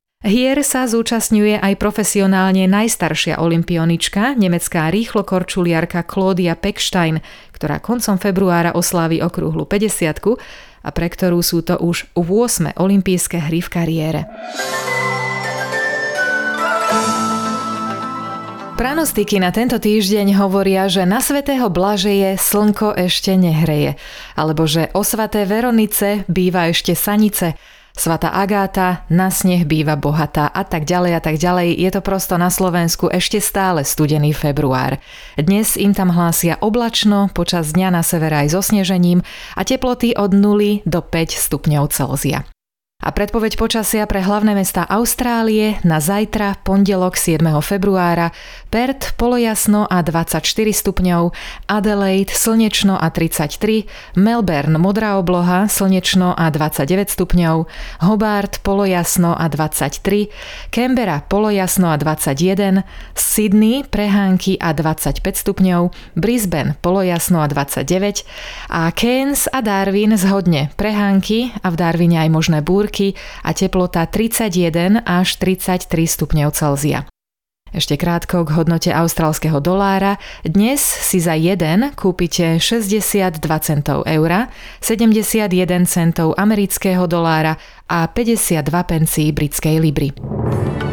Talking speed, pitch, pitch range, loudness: 115 wpm, 185 Hz, 165-210 Hz, -16 LUFS